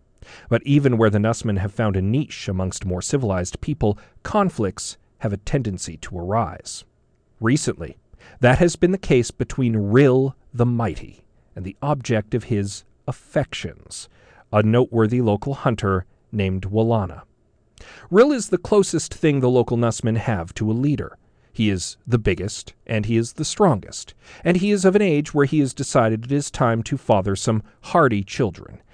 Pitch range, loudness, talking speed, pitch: 105-140 Hz, -21 LUFS, 165 wpm, 115 Hz